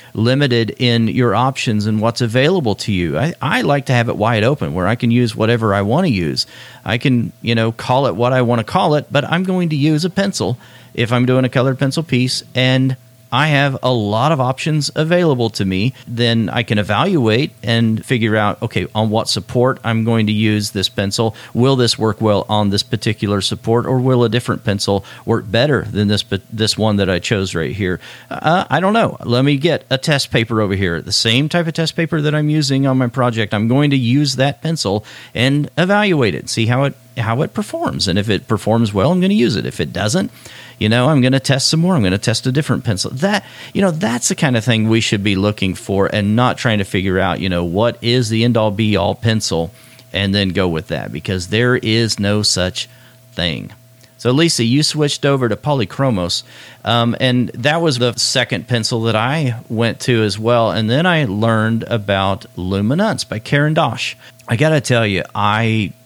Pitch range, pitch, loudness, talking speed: 110-135 Hz, 120 Hz, -16 LUFS, 225 wpm